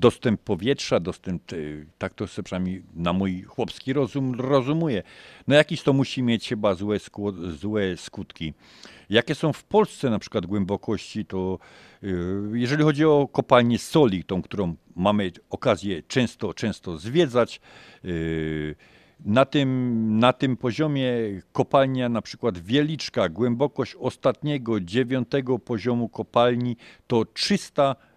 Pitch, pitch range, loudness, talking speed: 115 Hz, 95-135 Hz, -24 LUFS, 125 wpm